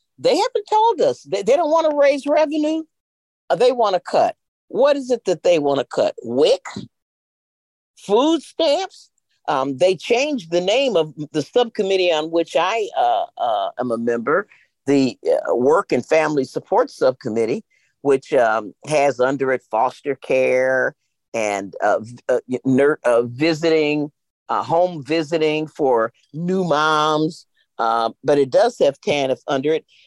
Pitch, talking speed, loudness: 165 Hz, 145 wpm, -19 LUFS